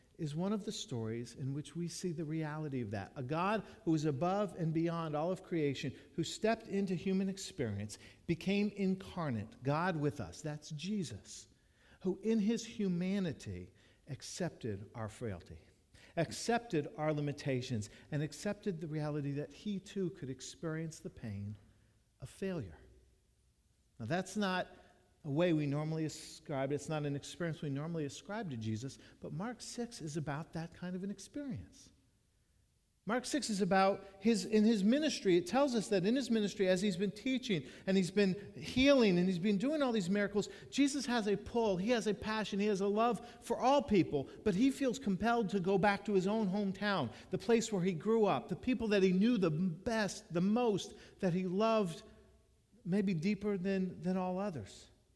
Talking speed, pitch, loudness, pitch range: 180 wpm, 185 Hz, -36 LUFS, 145-210 Hz